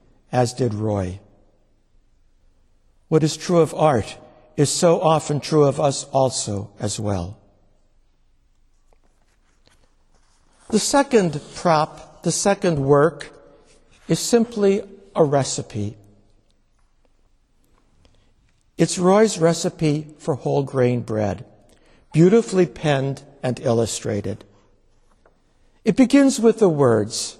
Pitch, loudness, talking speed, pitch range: 140 Hz, -20 LUFS, 95 wpm, 105-165 Hz